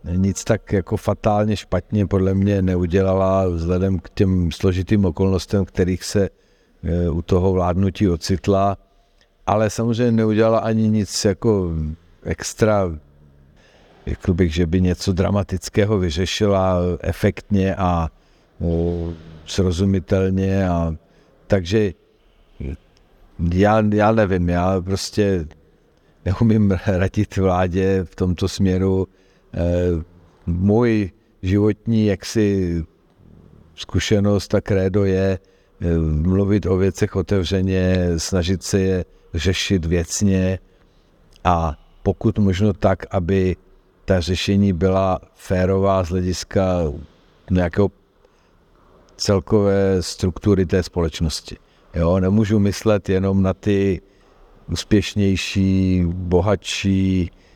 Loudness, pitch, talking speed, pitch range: -20 LUFS, 95 Hz, 90 wpm, 90-100 Hz